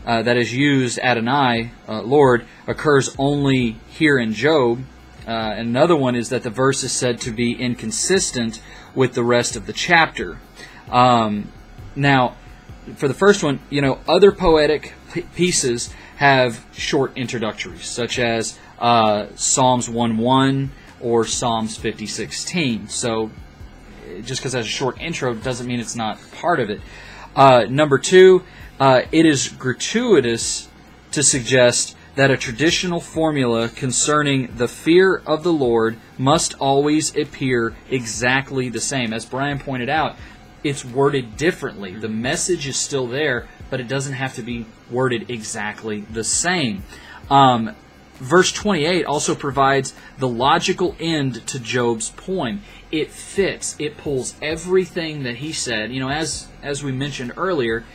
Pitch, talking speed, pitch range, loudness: 130 Hz, 145 wpm, 115-145 Hz, -19 LUFS